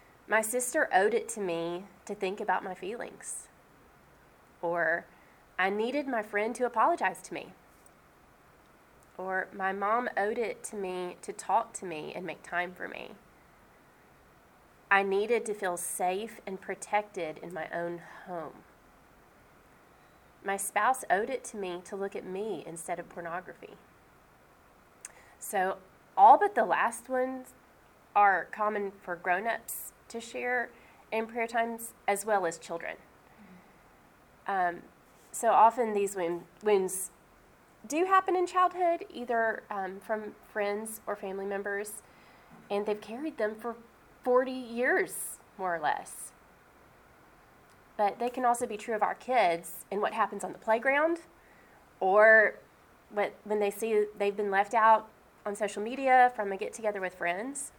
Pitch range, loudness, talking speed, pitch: 185-235 Hz, -30 LUFS, 140 wpm, 210 Hz